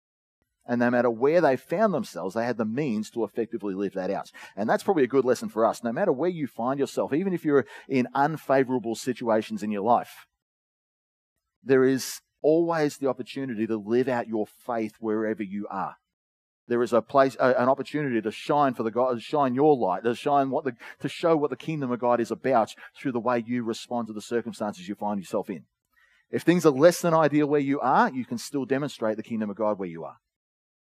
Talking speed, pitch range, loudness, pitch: 220 wpm, 110-140 Hz, -26 LUFS, 120 Hz